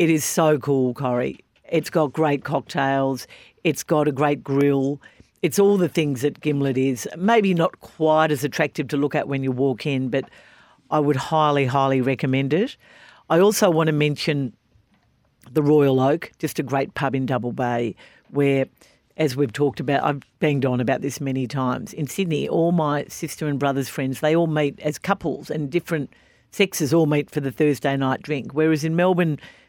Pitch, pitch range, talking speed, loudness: 145 Hz, 135-160 Hz, 190 wpm, -22 LUFS